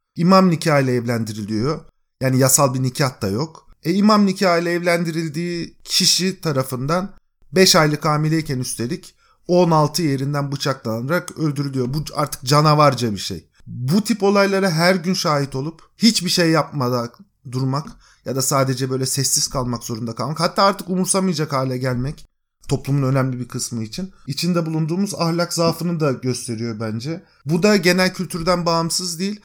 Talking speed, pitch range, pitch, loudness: 145 wpm, 130-180 Hz, 155 Hz, -19 LUFS